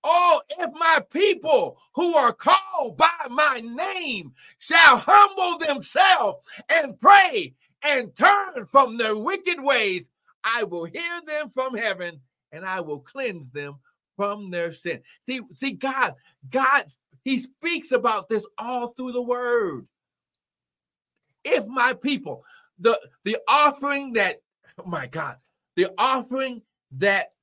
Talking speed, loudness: 130 wpm, -21 LUFS